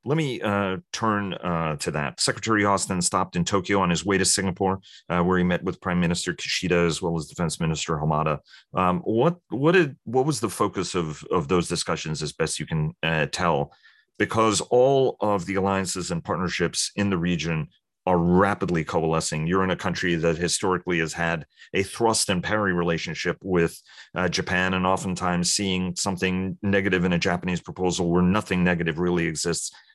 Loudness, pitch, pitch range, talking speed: -24 LUFS, 90 Hz, 85-100 Hz, 185 wpm